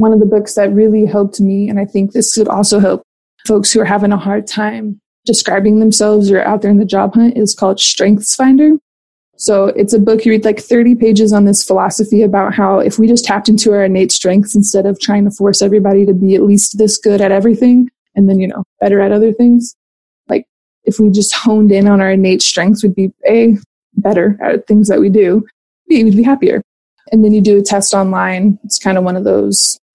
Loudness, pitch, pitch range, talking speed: -10 LUFS, 205 Hz, 200-220 Hz, 230 wpm